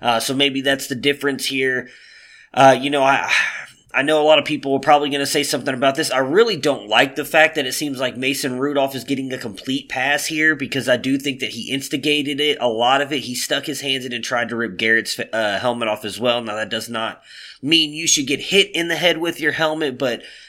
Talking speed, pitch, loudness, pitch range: 250 wpm, 140 Hz, -18 LUFS, 130-150 Hz